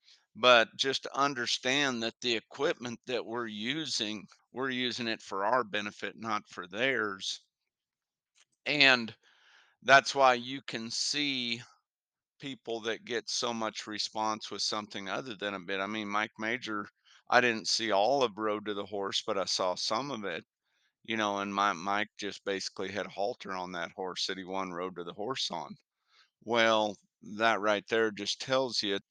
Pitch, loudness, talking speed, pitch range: 110 Hz, -31 LUFS, 170 wpm, 100-125 Hz